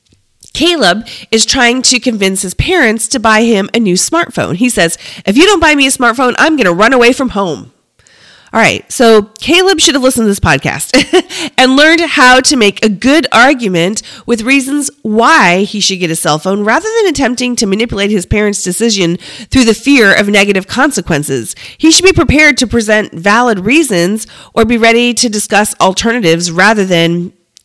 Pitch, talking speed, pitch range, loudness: 225 Hz, 185 wpm, 195-265 Hz, -9 LUFS